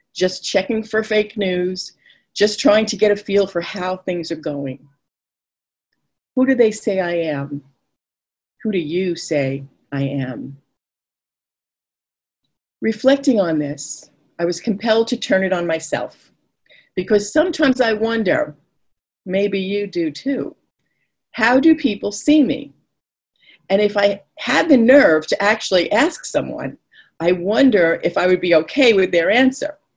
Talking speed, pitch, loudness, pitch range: 145 wpm, 195 Hz, -18 LUFS, 165-225 Hz